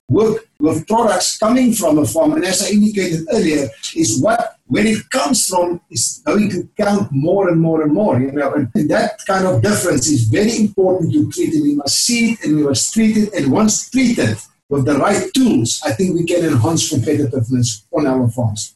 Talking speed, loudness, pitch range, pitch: 210 wpm, -15 LUFS, 145-225 Hz, 185 Hz